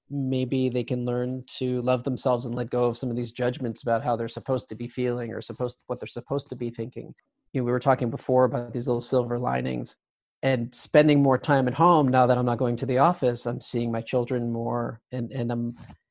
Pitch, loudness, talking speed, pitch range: 125 Hz, -26 LUFS, 235 wpm, 120-130 Hz